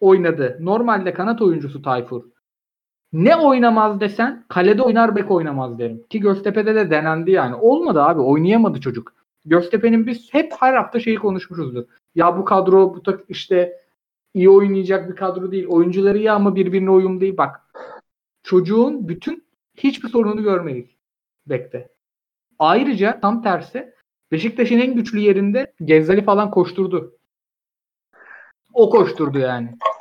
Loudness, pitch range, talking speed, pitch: -17 LUFS, 170-230 Hz, 130 wpm, 195 Hz